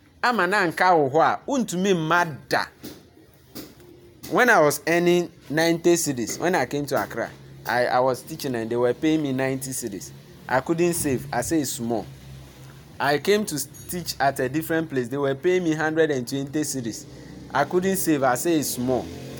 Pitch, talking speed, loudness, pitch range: 145 Hz, 185 wpm, -23 LUFS, 125-160 Hz